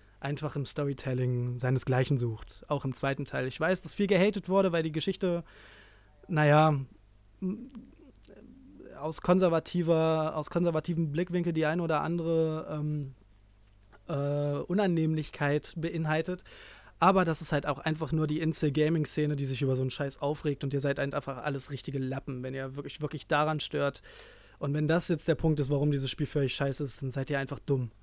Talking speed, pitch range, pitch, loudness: 170 wpm, 135-160 Hz, 150 Hz, -30 LUFS